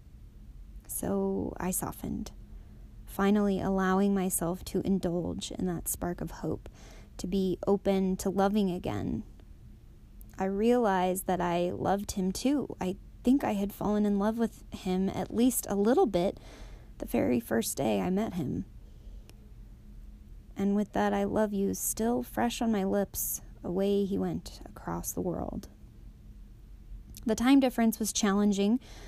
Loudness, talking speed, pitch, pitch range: -30 LUFS, 140 wpm, 195 Hz, 185-215 Hz